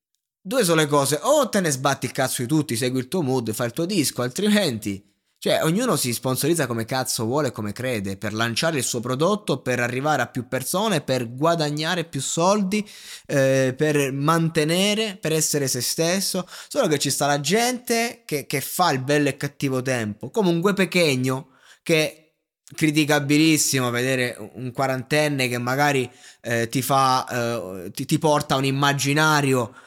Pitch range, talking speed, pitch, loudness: 125-160 Hz, 170 wpm, 140 Hz, -22 LUFS